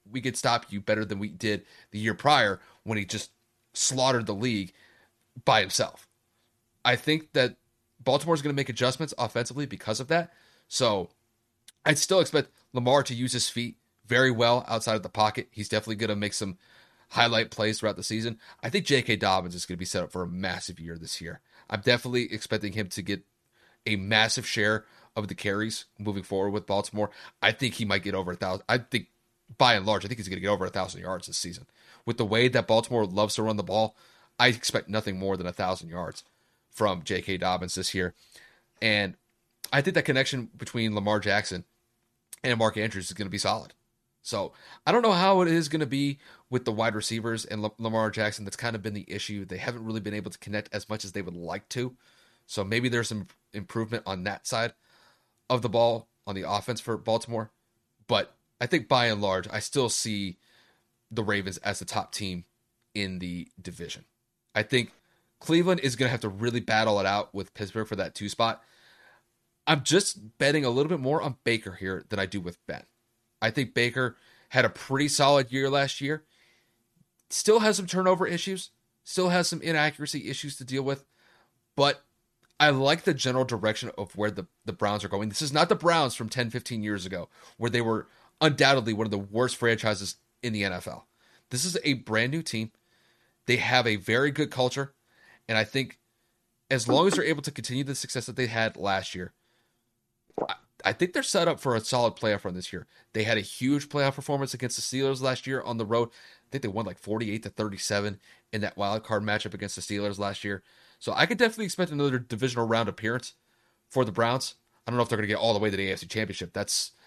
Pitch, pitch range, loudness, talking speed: 115 Hz, 105-130 Hz, -28 LUFS, 215 wpm